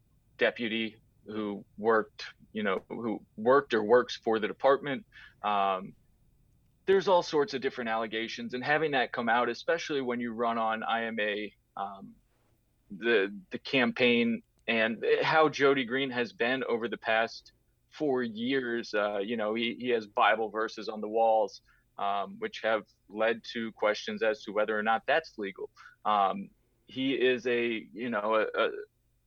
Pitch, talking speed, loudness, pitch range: 115 Hz, 160 wpm, -30 LUFS, 110-130 Hz